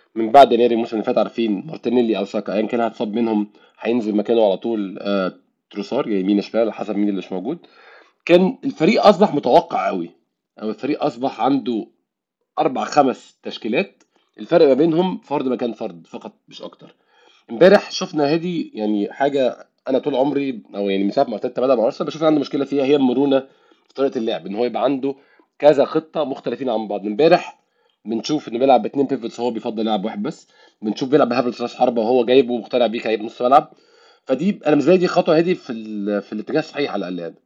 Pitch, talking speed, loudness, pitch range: 120 Hz, 190 wpm, -19 LUFS, 110-145 Hz